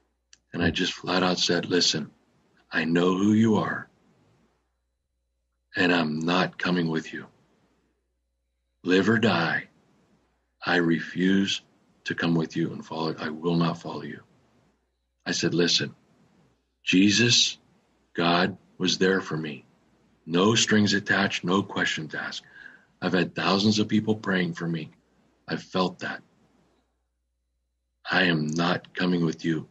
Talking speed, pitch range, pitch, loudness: 135 wpm, 65-95 Hz, 85 Hz, -25 LUFS